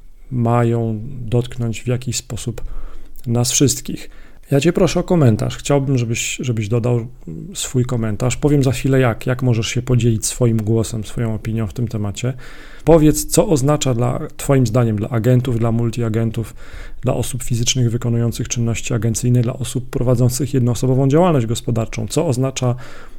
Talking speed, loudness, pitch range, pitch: 150 wpm, -18 LUFS, 115-130 Hz, 120 Hz